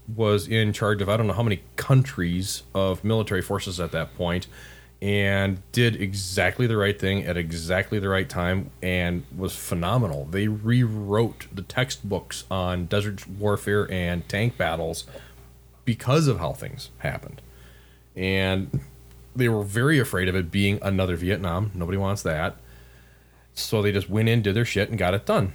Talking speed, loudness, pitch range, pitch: 165 wpm, -25 LUFS, 85-105 Hz, 95 Hz